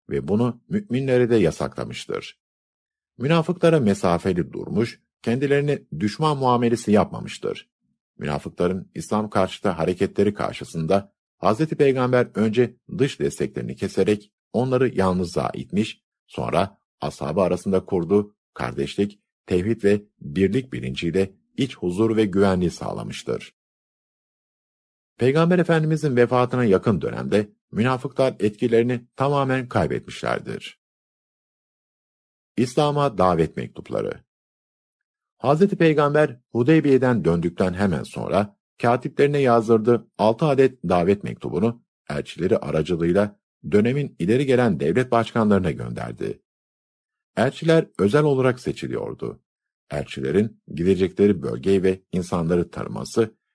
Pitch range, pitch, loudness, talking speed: 95-130 Hz, 110 Hz, -22 LUFS, 90 wpm